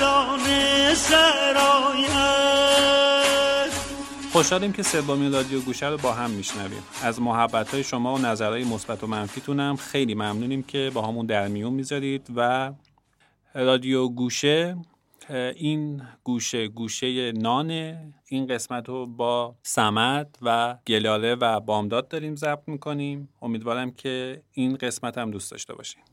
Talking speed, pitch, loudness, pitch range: 120 wpm, 130 Hz, -23 LUFS, 120-155 Hz